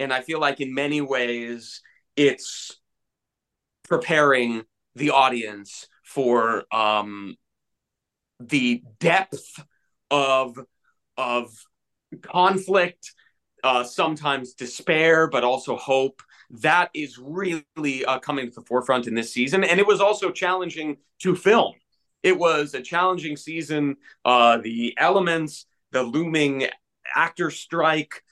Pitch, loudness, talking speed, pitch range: 140 Hz, -22 LUFS, 115 wpm, 125-160 Hz